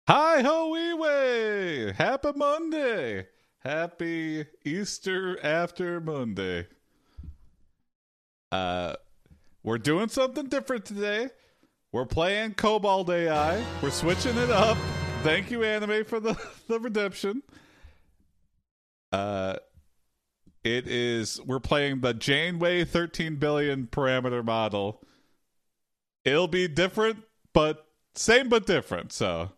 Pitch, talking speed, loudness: 165 Hz, 105 wpm, -27 LUFS